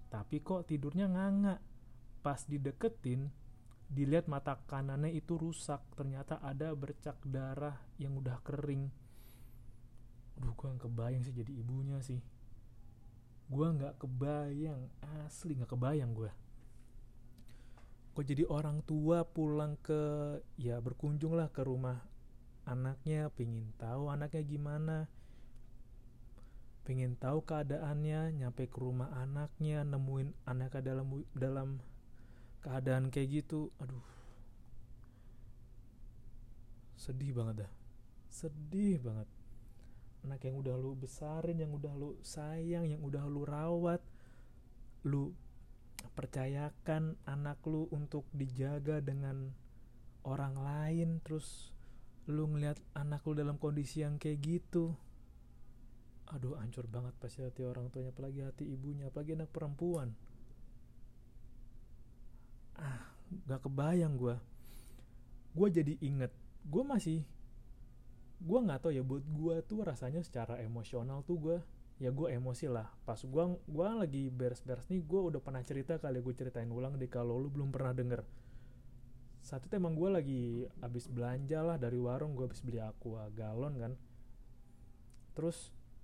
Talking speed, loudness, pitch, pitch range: 125 wpm, -40 LUFS, 135 Hz, 120-150 Hz